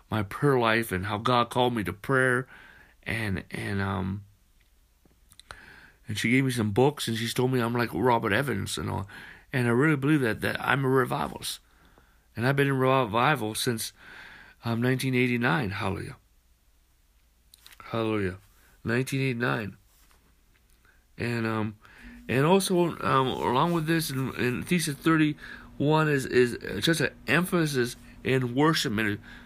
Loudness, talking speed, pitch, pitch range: -26 LUFS, 140 wpm, 120 Hz, 100-135 Hz